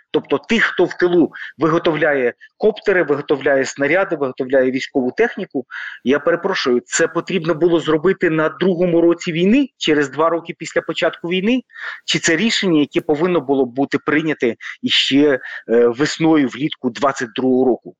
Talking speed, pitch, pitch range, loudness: 140 wpm, 165 Hz, 140-185 Hz, -17 LUFS